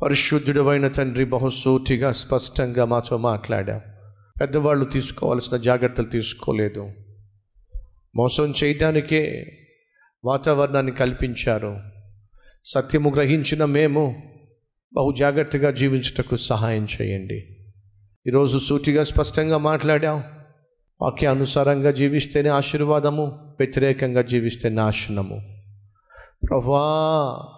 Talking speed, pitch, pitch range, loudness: 75 wpm, 135 Hz, 115-145 Hz, -21 LUFS